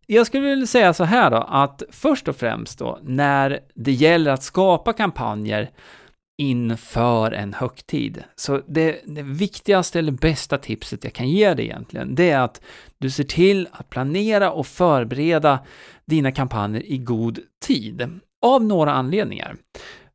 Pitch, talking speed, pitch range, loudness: 145 Hz, 150 wpm, 130-185 Hz, -20 LUFS